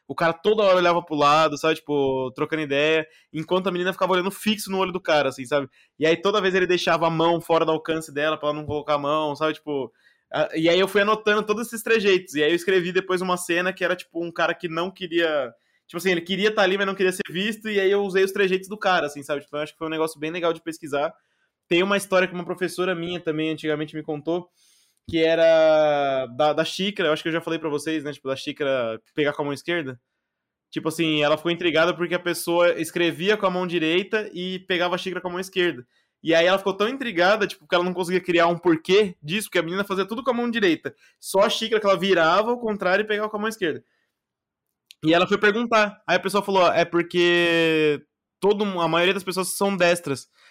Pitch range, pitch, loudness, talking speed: 160-190 Hz, 175 Hz, -22 LUFS, 250 wpm